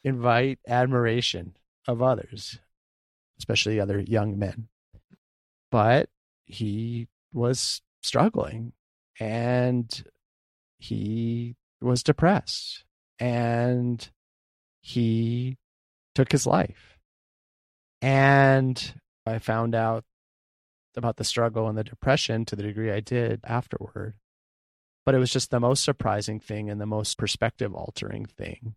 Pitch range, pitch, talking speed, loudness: 100-125 Hz, 115 Hz, 105 wpm, -26 LUFS